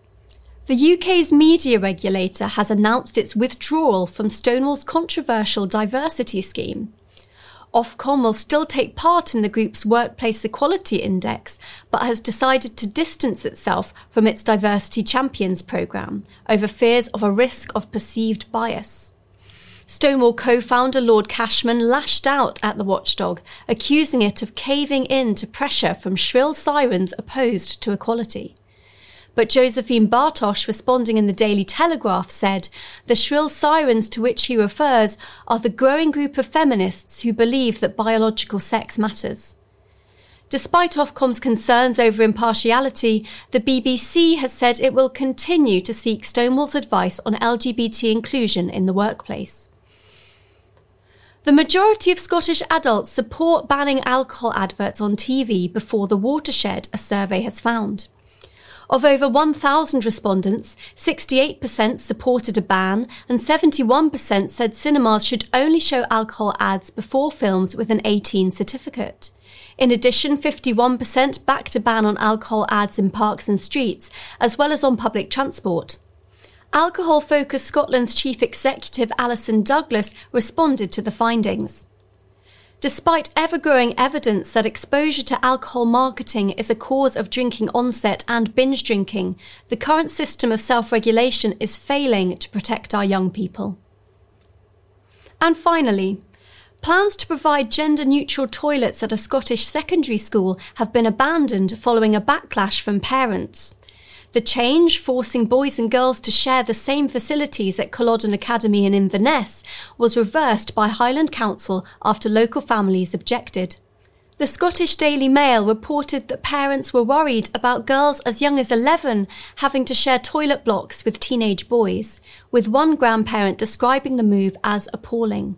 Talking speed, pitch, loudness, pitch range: 140 wpm, 235 Hz, -19 LUFS, 210-270 Hz